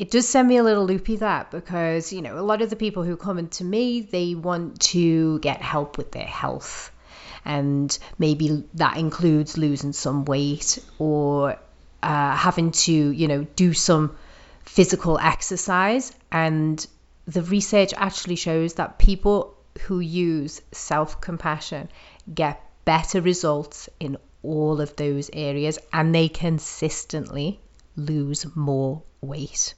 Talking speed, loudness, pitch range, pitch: 140 wpm, -23 LUFS, 150-180 Hz, 160 Hz